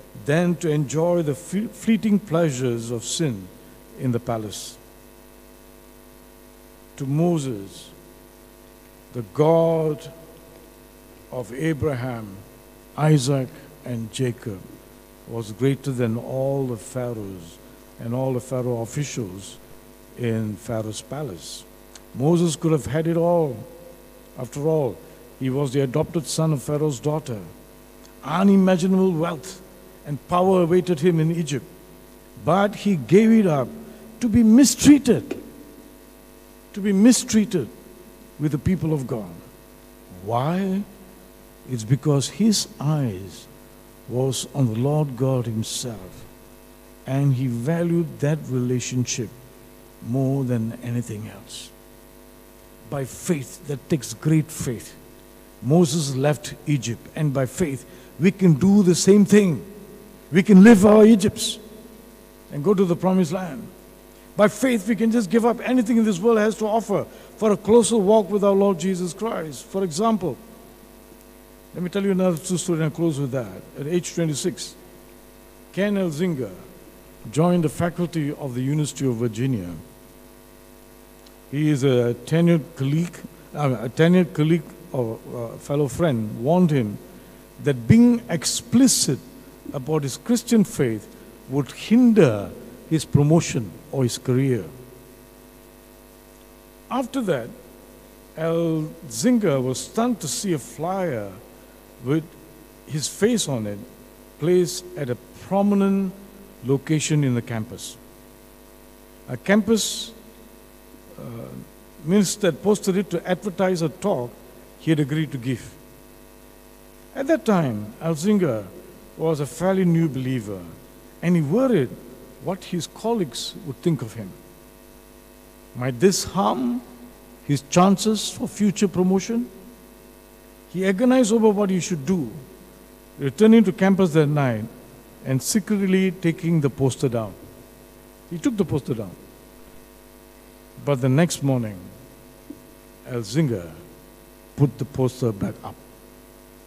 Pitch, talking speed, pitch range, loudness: 140 Hz, 120 wpm, 115-180 Hz, -21 LUFS